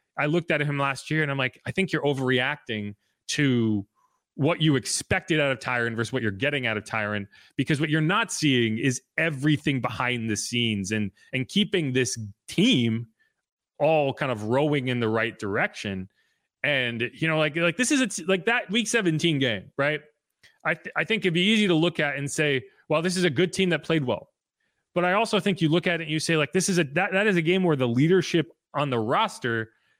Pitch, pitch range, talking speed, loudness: 150 Hz, 125-170 Hz, 225 wpm, -25 LUFS